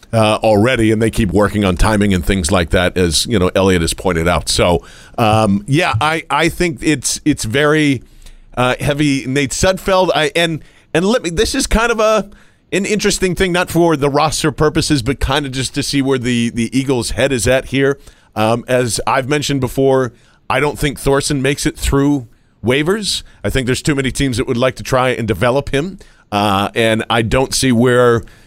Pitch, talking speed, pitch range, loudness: 130 Hz, 205 wpm, 110-150 Hz, -15 LUFS